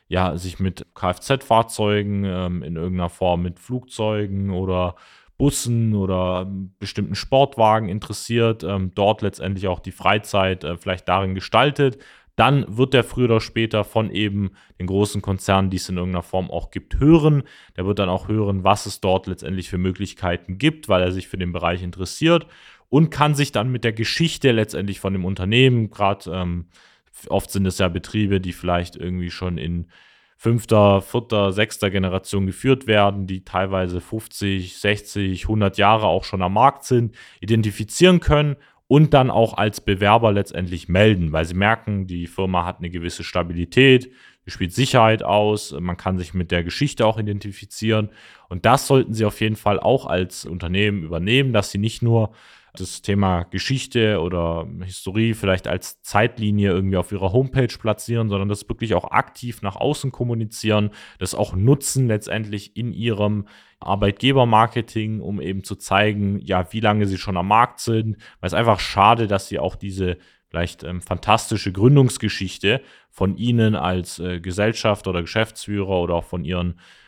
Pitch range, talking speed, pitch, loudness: 90-110 Hz, 160 wpm, 100 Hz, -20 LUFS